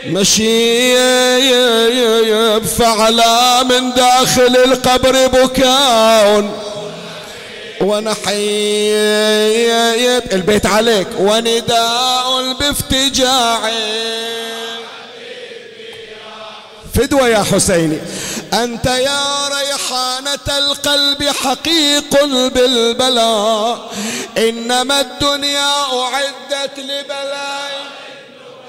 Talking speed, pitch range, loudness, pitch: 50 wpm, 220-270 Hz, -12 LUFS, 245 Hz